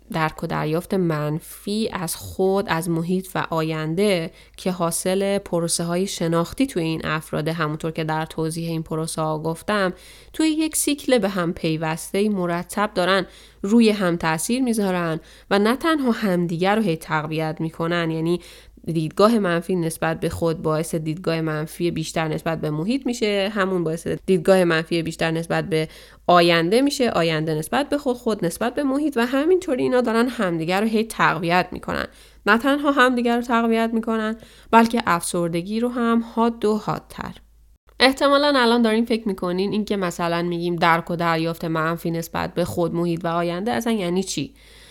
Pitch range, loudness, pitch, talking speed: 165-225 Hz, -21 LUFS, 175 Hz, 160 wpm